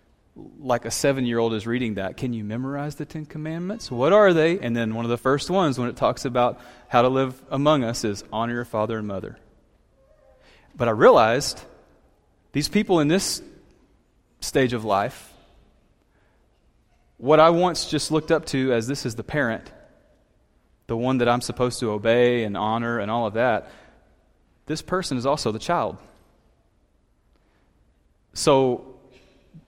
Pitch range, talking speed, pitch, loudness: 115-145 Hz, 165 wpm, 125 Hz, -23 LUFS